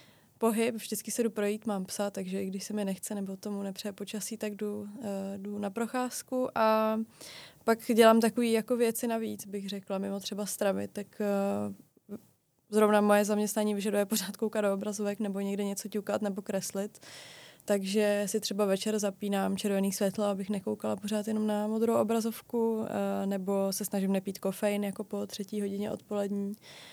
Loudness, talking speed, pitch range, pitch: -31 LUFS, 165 wpm, 200-215 Hz, 205 Hz